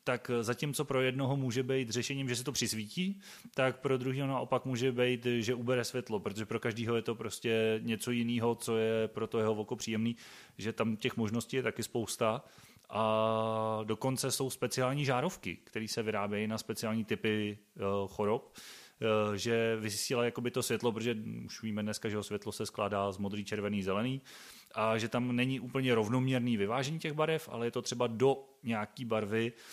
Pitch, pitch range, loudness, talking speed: 115 Hz, 110-130 Hz, -34 LUFS, 175 wpm